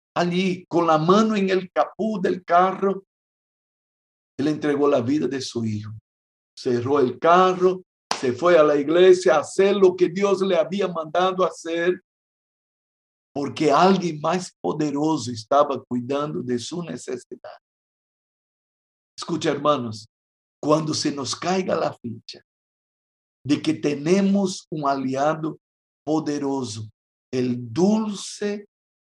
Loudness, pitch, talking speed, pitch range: -22 LUFS, 160 Hz, 120 wpm, 130-185 Hz